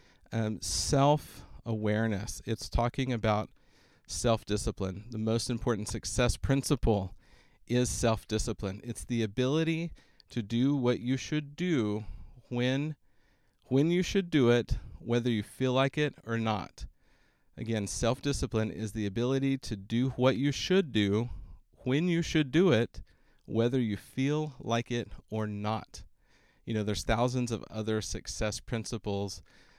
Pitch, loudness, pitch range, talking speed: 115 Hz, -31 LUFS, 105-130 Hz, 135 wpm